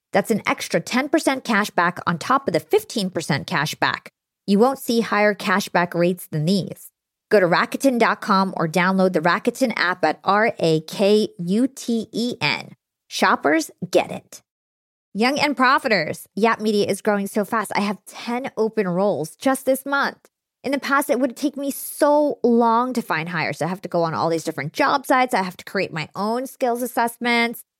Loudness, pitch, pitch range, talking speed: -21 LUFS, 215 Hz, 180-250 Hz, 190 wpm